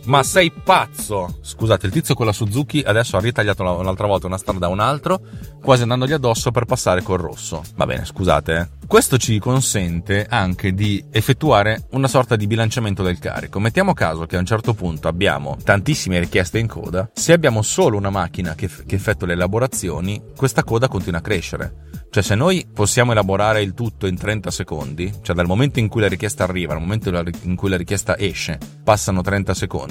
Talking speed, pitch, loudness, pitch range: 195 wpm, 100 Hz, -19 LUFS, 90-115 Hz